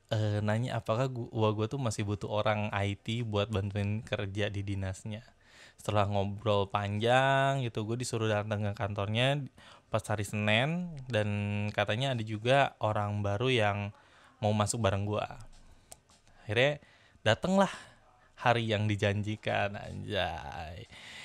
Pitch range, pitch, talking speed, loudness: 105-120 Hz, 105 Hz, 120 wpm, -31 LUFS